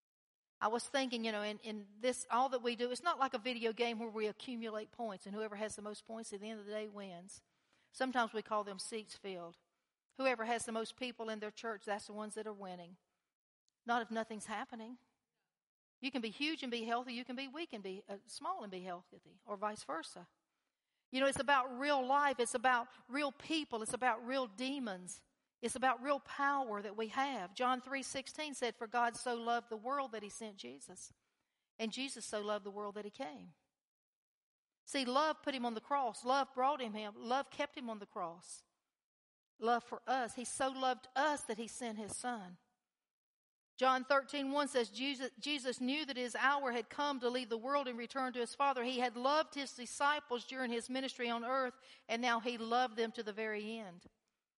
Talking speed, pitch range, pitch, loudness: 210 wpm, 220-265 Hz, 240 Hz, -39 LUFS